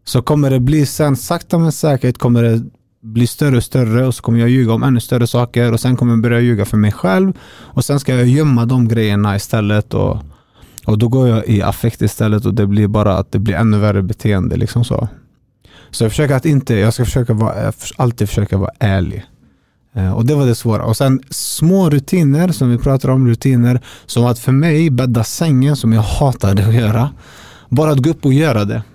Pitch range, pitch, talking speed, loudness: 110-135 Hz, 120 Hz, 220 wpm, -14 LUFS